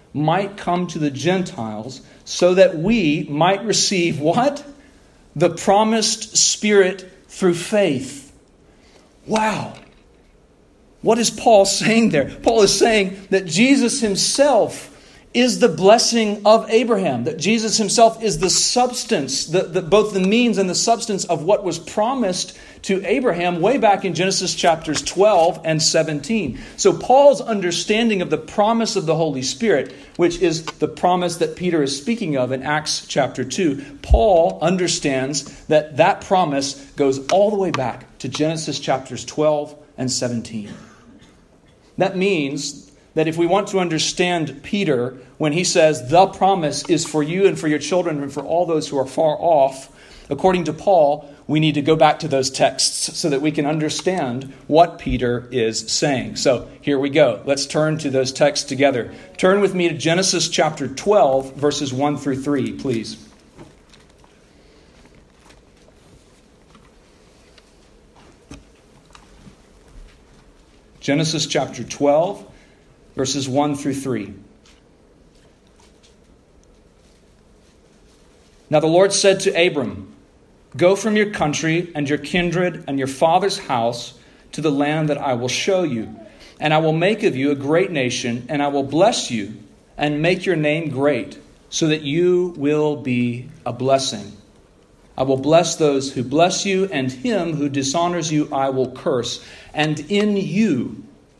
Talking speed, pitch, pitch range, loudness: 145 wpm, 160 Hz, 140-190 Hz, -18 LUFS